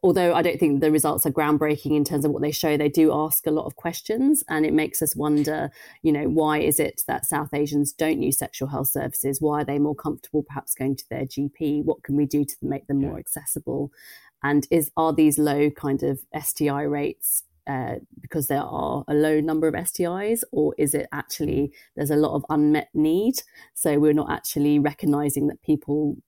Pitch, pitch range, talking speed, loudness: 150 Hz, 145-155 Hz, 210 wpm, -23 LUFS